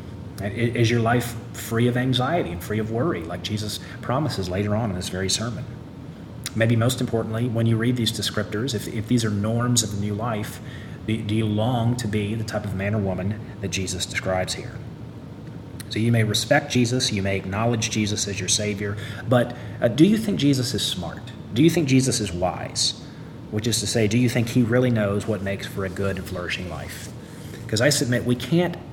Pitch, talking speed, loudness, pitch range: 115 Hz, 205 wpm, -23 LUFS, 105-125 Hz